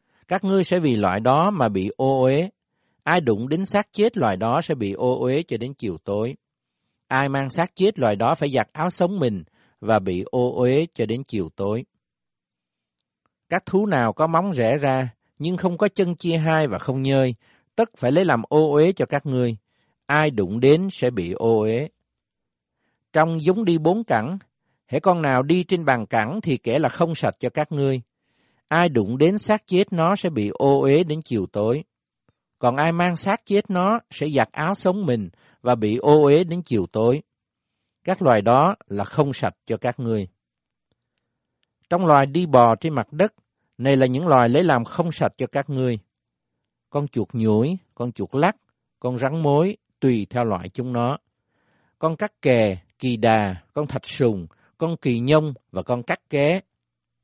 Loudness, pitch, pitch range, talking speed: -21 LUFS, 135 Hz, 115-165 Hz, 190 wpm